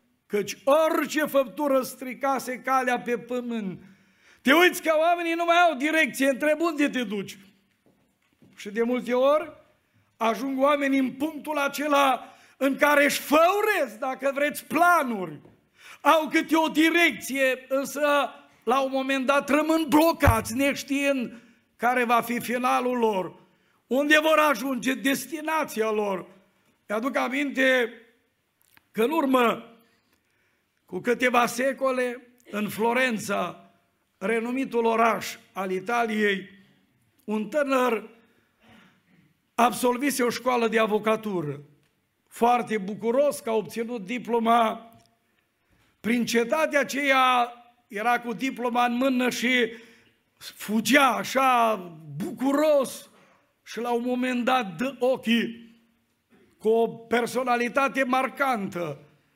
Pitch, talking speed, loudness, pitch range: 250 Hz, 110 wpm, -24 LUFS, 225-275 Hz